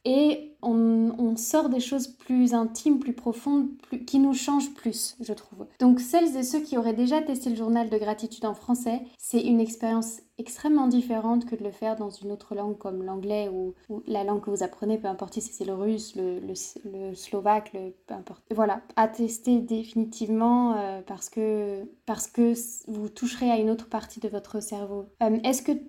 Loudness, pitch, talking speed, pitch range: -27 LUFS, 225 Hz, 200 wpm, 210-245 Hz